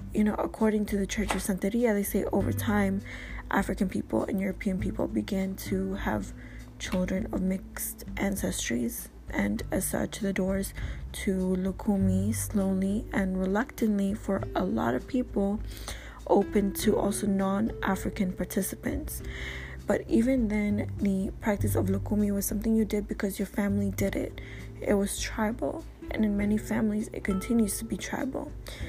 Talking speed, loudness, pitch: 150 wpm, -29 LUFS, 195 Hz